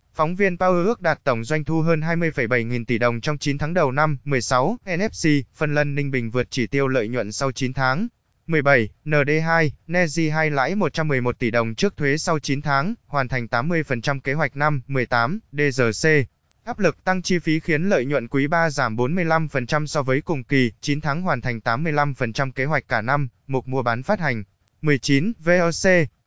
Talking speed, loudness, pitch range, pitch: 195 wpm, -21 LUFS, 125-160 Hz, 145 Hz